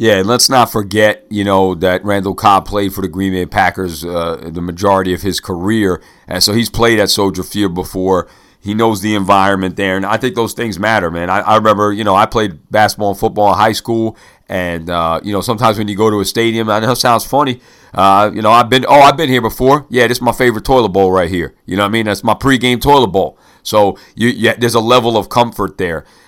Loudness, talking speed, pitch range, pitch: -12 LUFS, 250 wpm, 95-115 Hz, 105 Hz